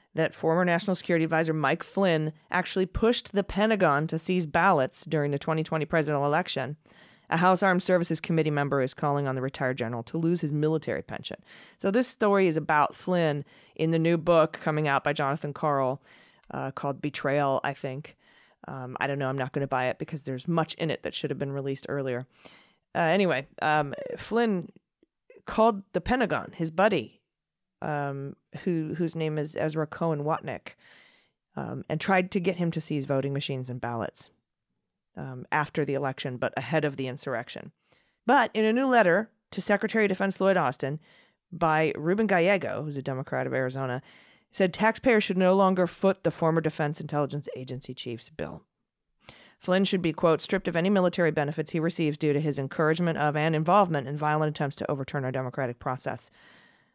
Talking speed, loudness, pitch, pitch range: 180 wpm, -27 LUFS, 155 Hz, 140-180 Hz